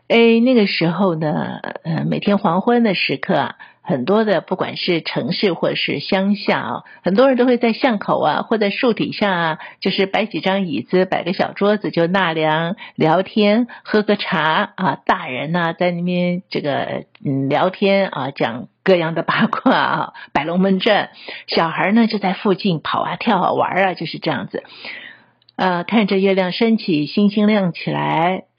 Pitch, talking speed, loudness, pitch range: 195 Hz, 250 characters per minute, -18 LUFS, 170-210 Hz